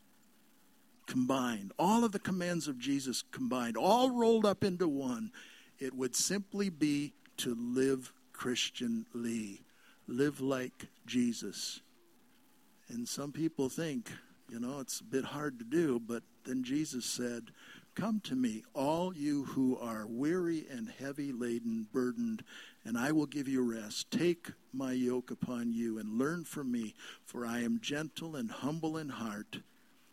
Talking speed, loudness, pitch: 145 wpm, -36 LUFS, 145 Hz